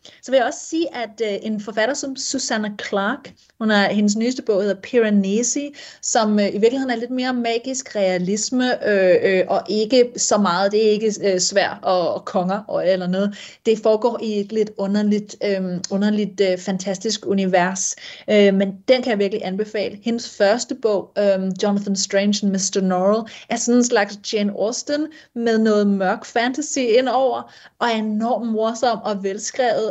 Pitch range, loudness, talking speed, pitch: 200-235 Hz, -20 LUFS, 180 wpm, 215 Hz